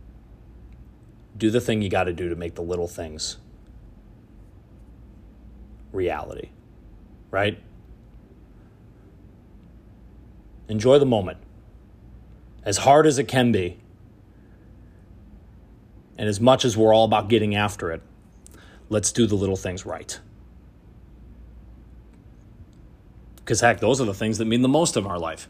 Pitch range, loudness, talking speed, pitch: 95-115 Hz, -22 LUFS, 120 wpm, 105 Hz